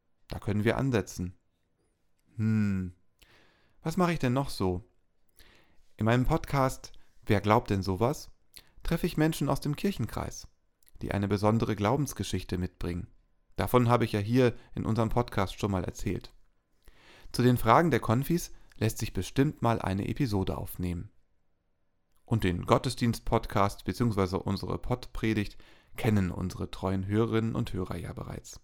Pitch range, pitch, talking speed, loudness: 95-120 Hz, 110 Hz, 140 wpm, -30 LUFS